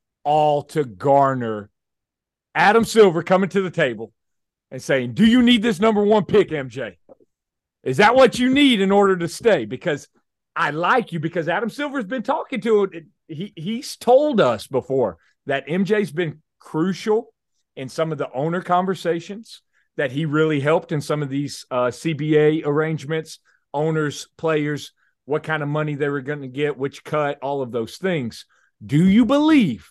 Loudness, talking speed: -20 LUFS, 175 wpm